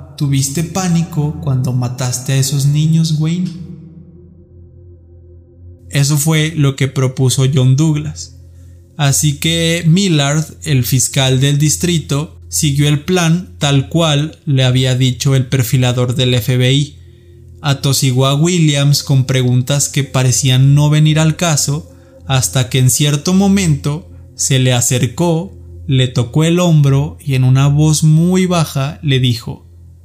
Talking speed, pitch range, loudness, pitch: 130 wpm, 125-155 Hz, -13 LUFS, 140 Hz